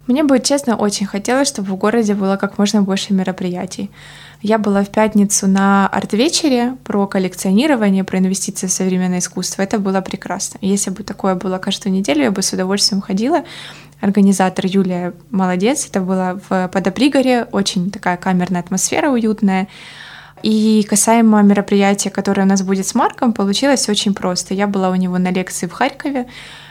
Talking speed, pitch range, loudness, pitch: 160 wpm, 190-220 Hz, -16 LUFS, 200 Hz